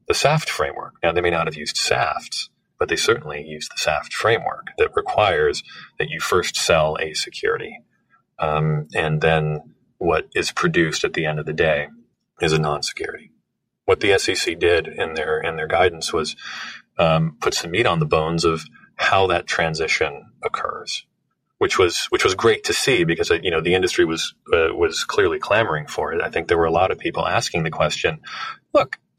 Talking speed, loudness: 190 wpm, -20 LUFS